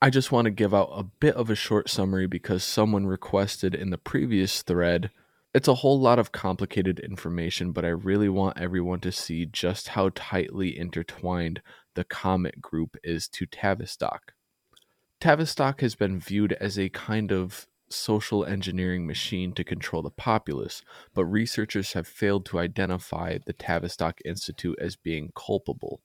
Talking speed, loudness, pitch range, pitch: 160 wpm, -27 LUFS, 90-105 Hz, 95 Hz